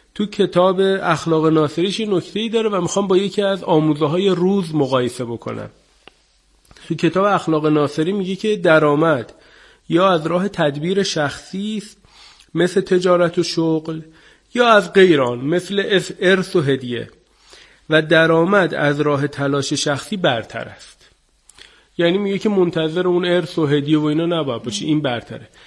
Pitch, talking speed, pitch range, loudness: 170 Hz, 145 wpm, 155-190 Hz, -17 LUFS